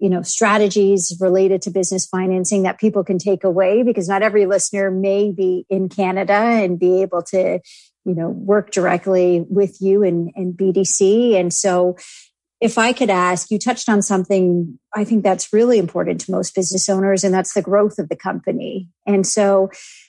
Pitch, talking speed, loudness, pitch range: 195 Hz, 180 wpm, -17 LUFS, 185-205 Hz